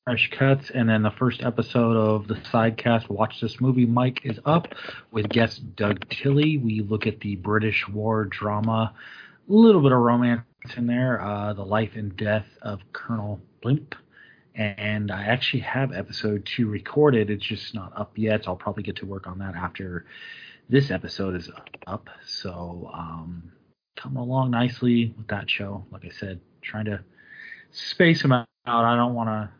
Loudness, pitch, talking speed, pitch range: -24 LUFS, 110 Hz, 175 wpm, 105-125 Hz